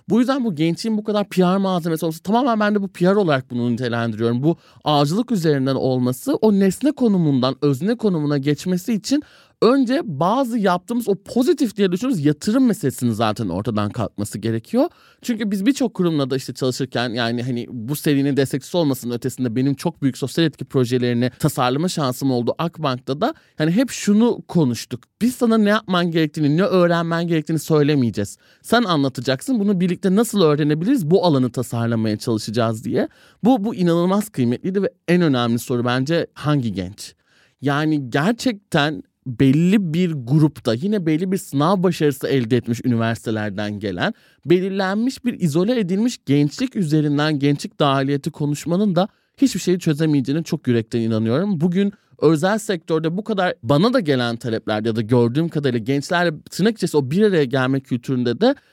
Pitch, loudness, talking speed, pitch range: 155 Hz, -20 LUFS, 155 wpm, 130-195 Hz